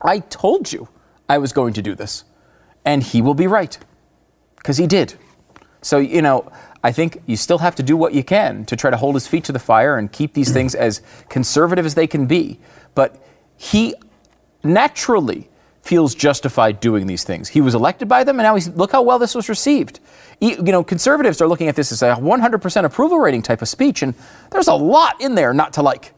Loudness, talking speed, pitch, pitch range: -16 LUFS, 220 wpm, 150 Hz, 125-195 Hz